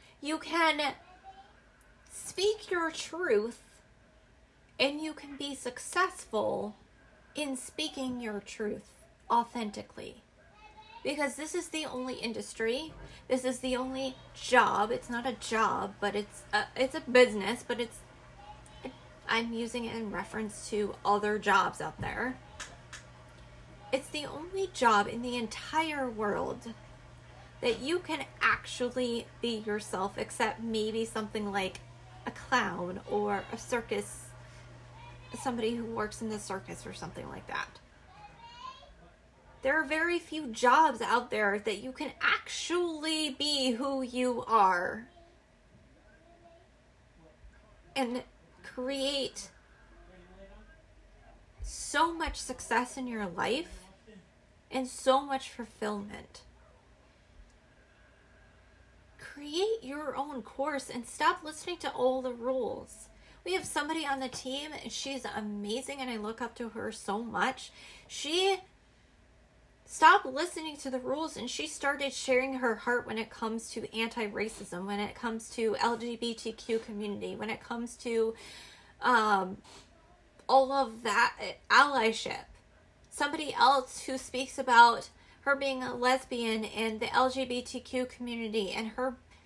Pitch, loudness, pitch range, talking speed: 250 Hz, -32 LUFS, 225-280 Hz, 125 wpm